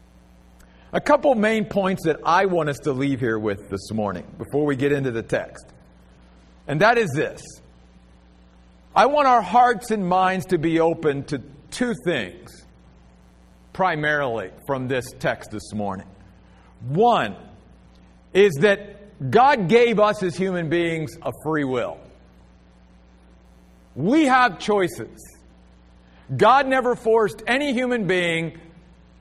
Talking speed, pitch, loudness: 130 wpm, 135 Hz, -21 LUFS